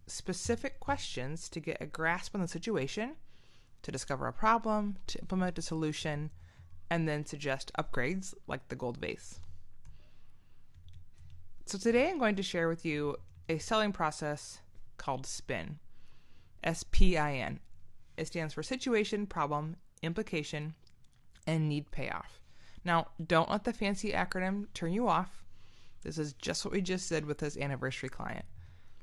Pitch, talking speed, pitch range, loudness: 155 Hz, 145 wpm, 120-185 Hz, -35 LUFS